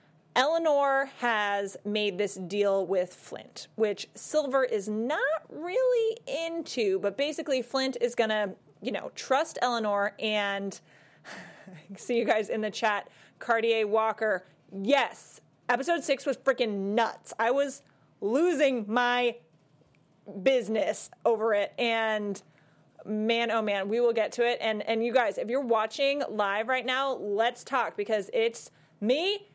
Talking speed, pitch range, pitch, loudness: 140 wpm, 205-265 Hz, 225 Hz, -28 LUFS